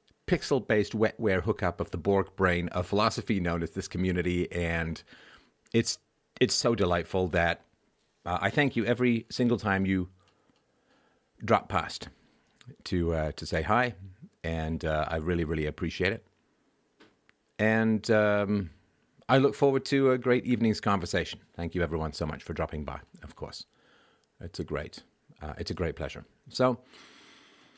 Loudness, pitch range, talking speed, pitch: -29 LUFS, 85-115 Hz, 150 wpm, 95 Hz